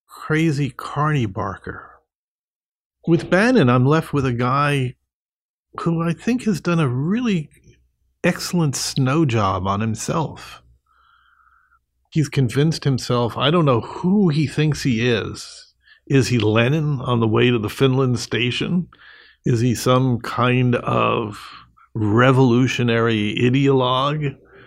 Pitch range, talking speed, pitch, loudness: 120-165 Hz, 120 wpm, 135 Hz, -19 LUFS